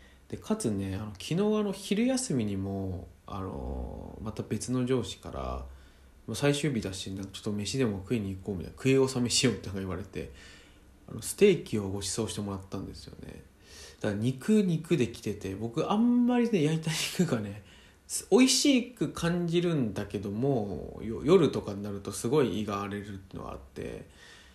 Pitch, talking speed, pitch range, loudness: 105 Hz, 325 characters per minute, 95-145 Hz, -30 LUFS